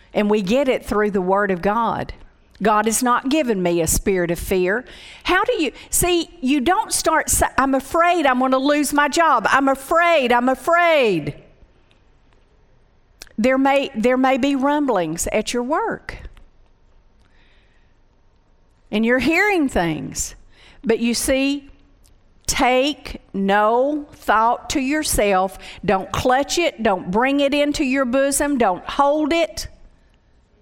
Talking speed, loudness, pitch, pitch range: 135 wpm, -18 LUFS, 255 Hz, 195-290 Hz